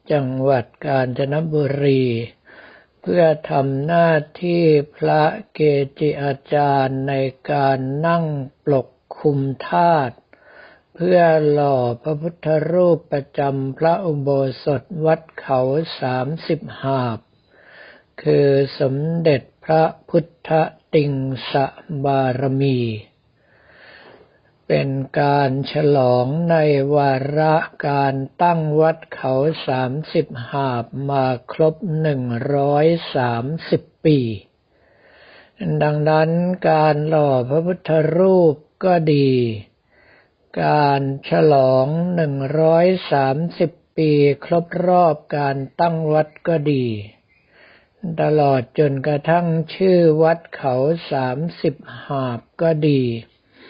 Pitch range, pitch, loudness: 135-160 Hz, 145 Hz, -18 LUFS